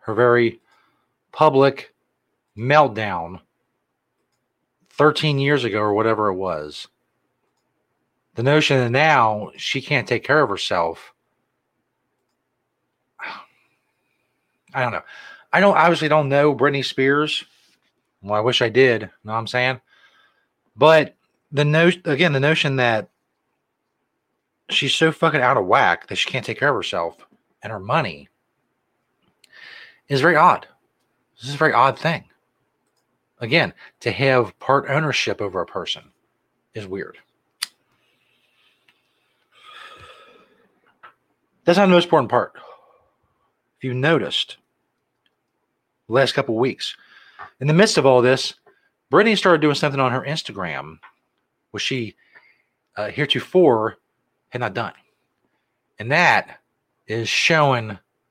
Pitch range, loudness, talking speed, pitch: 120-155 Hz, -19 LUFS, 125 wpm, 140 Hz